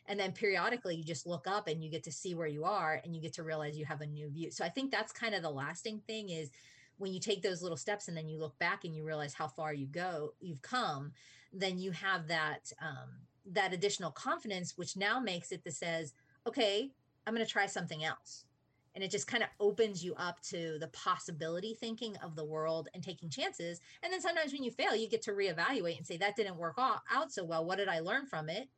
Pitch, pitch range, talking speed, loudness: 175 Hz, 160-205 Hz, 245 wpm, -38 LUFS